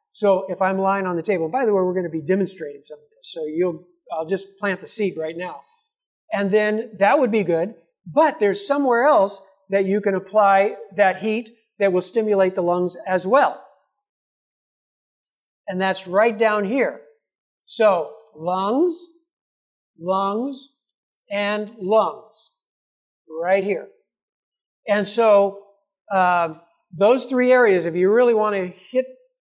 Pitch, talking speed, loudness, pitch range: 200 Hz, 150 wpm, -20 LUFS, 185-240 Hz